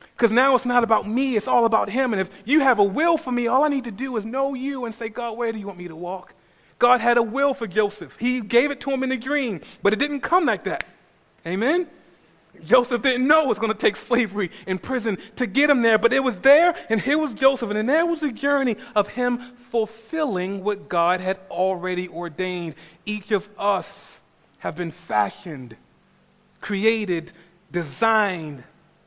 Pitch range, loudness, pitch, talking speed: 190-260 Hz, -22 LUFS, 225 Hz, 210 wpm